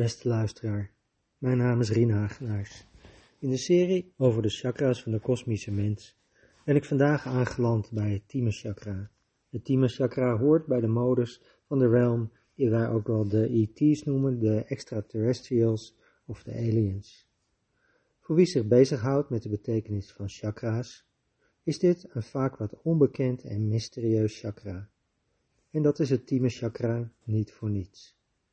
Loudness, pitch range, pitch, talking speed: -28 LUFS, 105-130 Hz, 115 Hz, 155 wpm